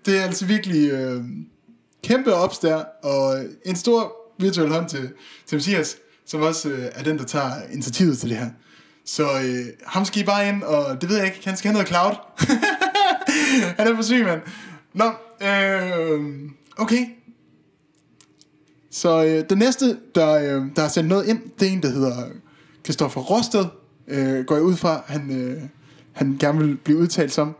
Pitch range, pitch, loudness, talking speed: 145-205 Hz, 165 Hz, -21 LUFS, 180 wpm